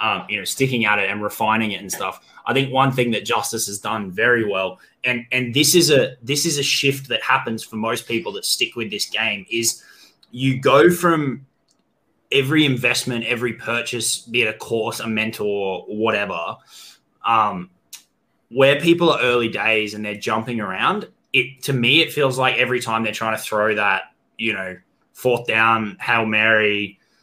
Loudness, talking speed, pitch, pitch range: -19 LUFS, 185 wpm, 115 Hz, 110-130 Hz